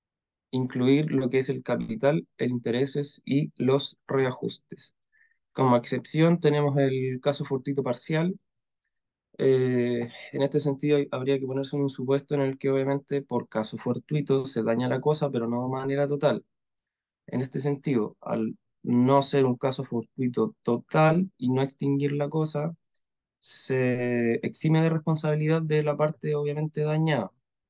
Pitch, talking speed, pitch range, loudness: 140 Hz, 145 wpm, 130-150 Hz, -27 LUFS